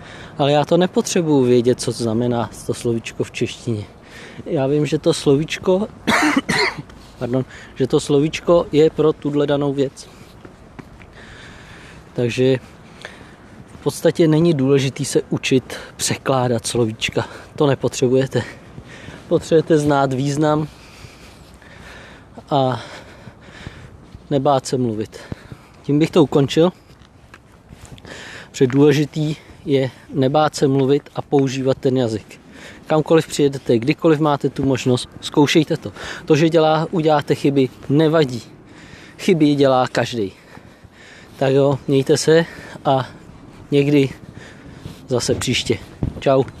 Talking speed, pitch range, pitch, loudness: 110 wpm, 125-155 Hz, 140 Hz, -18 LUFS